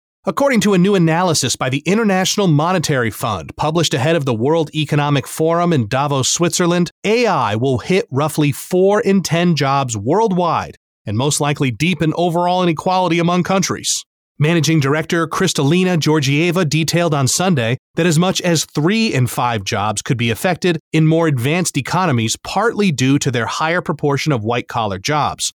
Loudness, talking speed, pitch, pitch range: -16 LUFS, 160 wpm, 160 Hz, 140-180 Hz